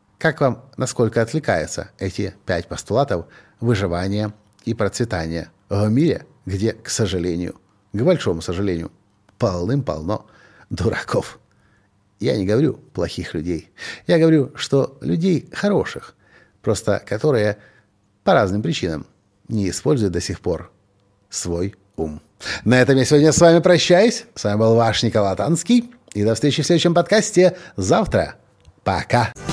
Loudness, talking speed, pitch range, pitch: -19 LUFS, 130 wpm, 95-135 Hz, 105 Hz